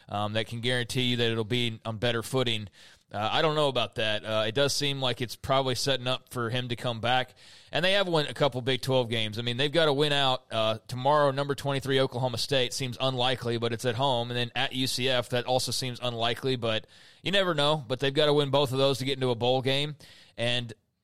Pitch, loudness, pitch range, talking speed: 125 Hz, -27 LUFS, 120-140 Hz, 245 wpm